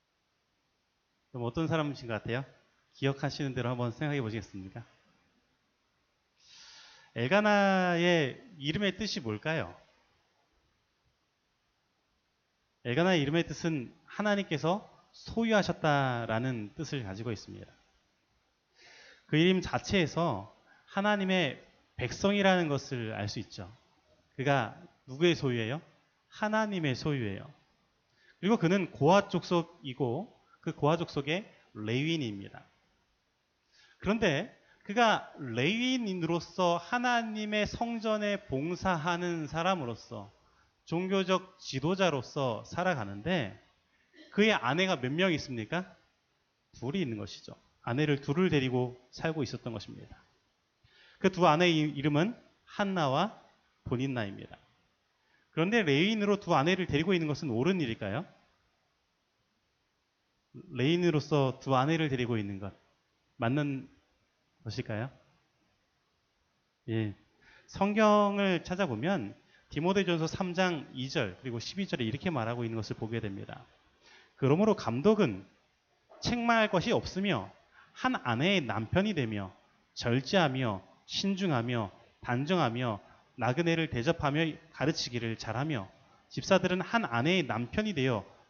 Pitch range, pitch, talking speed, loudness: 120-185 Hz, 150 Hz, 250 characters per minute, -31 LUFS